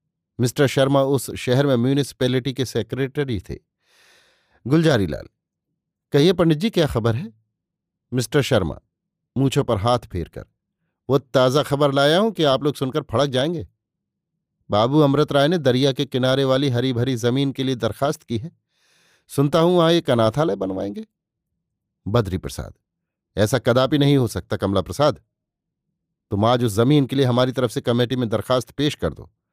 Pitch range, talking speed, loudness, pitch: 115-140 Hz, 160 wpm, -20 LUFS, 130 Hz